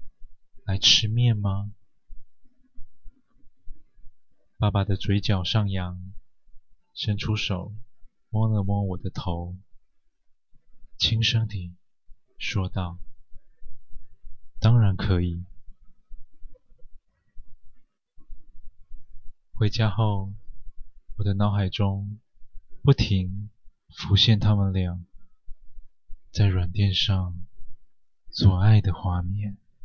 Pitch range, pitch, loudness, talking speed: 95-110 Hz, 105 Hz, -24 LUFS, 105 characters per minute